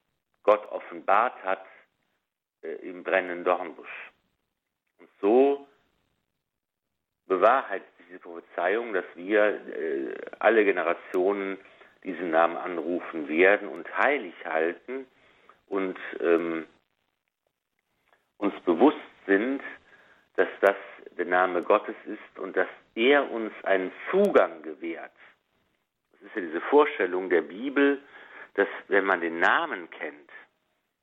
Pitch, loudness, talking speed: 130 Hz, -26 LUFS, 110 wpm